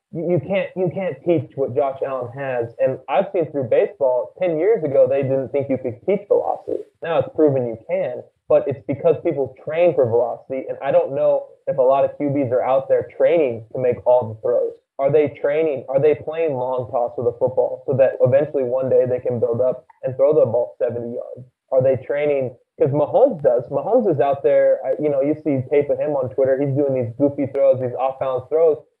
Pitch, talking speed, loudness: 165 Hz, 225 wpm, -20 LUFS